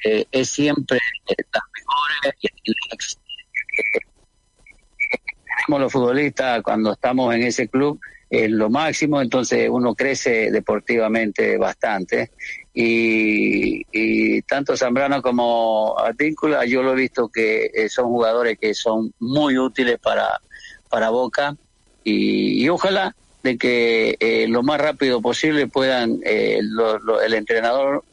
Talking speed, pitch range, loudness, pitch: 130 wpm, 115-145 Hz, -19 LUFS, 125 Hz